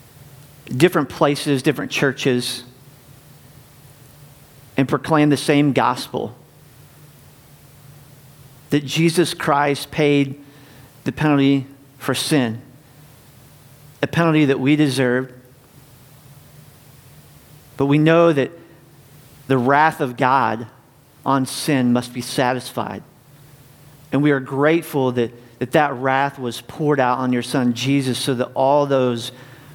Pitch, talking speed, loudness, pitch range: 140 Hz, 110 wpm, -19 LUFS, 130-145 Hz